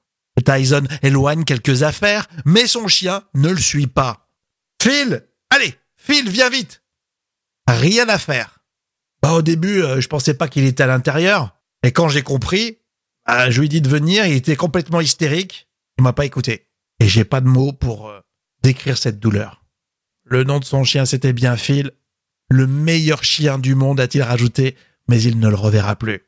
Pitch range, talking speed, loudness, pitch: 125-160 Hz, 185 wpm, -16 LUFS, 140 Hz